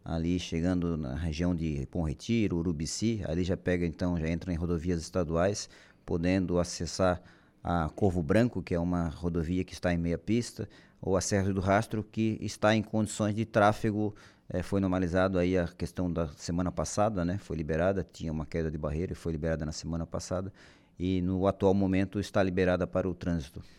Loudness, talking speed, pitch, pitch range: -31 LUFS, 185 wpm, 90 Hz, 85-100 Hz